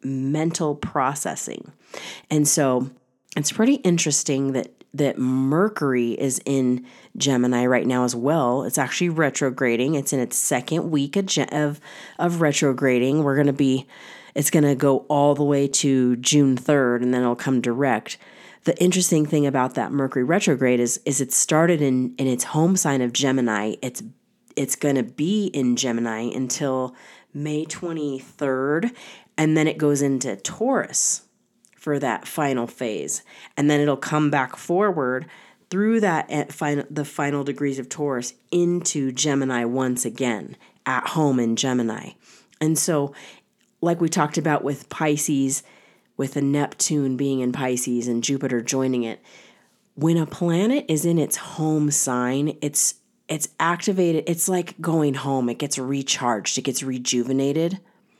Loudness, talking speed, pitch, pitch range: -22 LUFS, 150 wpm, 140 Hz, 130-155 Hz